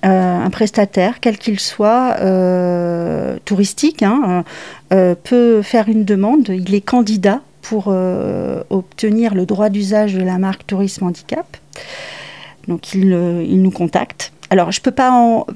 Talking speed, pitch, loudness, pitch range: 145 wpm, 195 Hz, -15 LUFS, 185-220 Hz